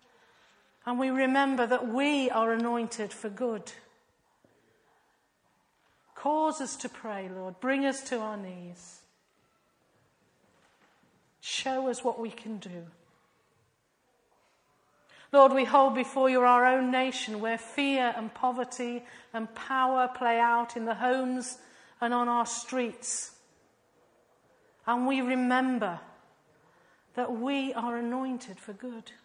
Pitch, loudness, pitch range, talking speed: 245 Hz, -29 LUFS, 230-255 Hz, 115 wpm